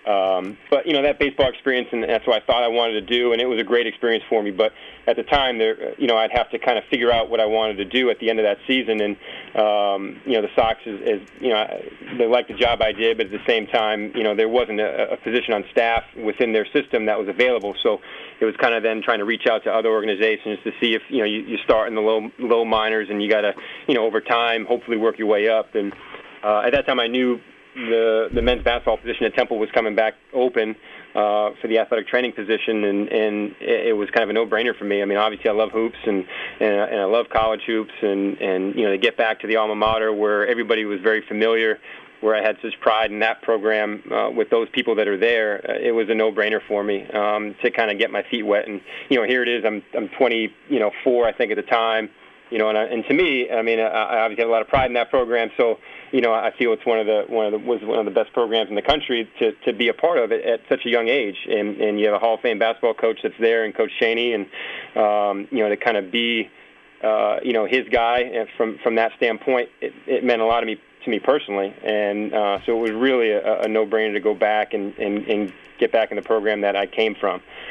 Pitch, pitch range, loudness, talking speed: 110 Hz, 105-120 Hz, -21 LUFS, 270 wpm